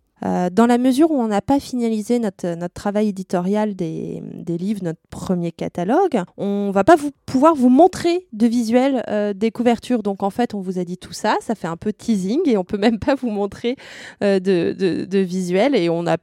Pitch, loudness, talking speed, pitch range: 210 Hz, -19 LUFS, 220 wpm, 190-240 Hz